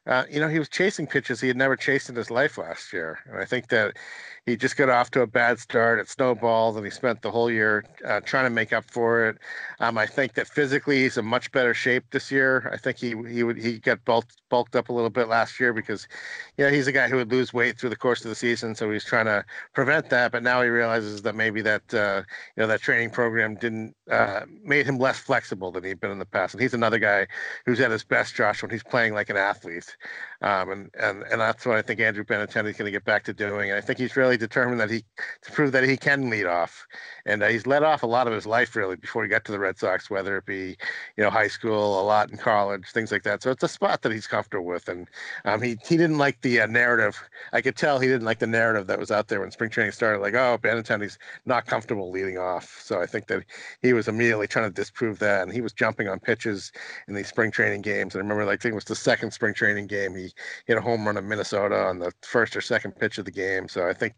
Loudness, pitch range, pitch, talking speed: -24 LUFS, 105-125 Hz, 115 Hz, 270 wpm